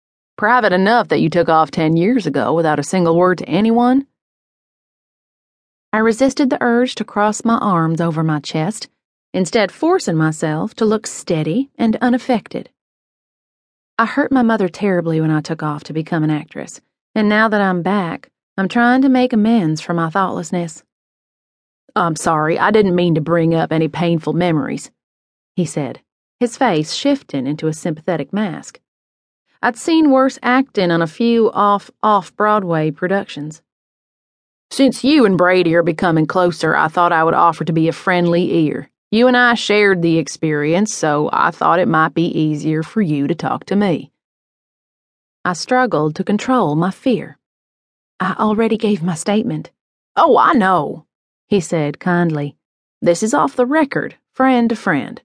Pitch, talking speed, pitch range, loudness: 185 Hz, 165 wpm, 160-225 Hz, -16 LUFS